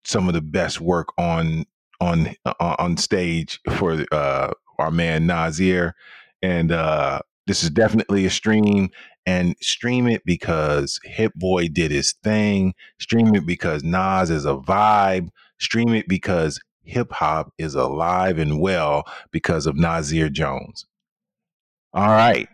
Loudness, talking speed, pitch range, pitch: -21 LUFS, 140 wpm, 80-100 Hz, 90 Hz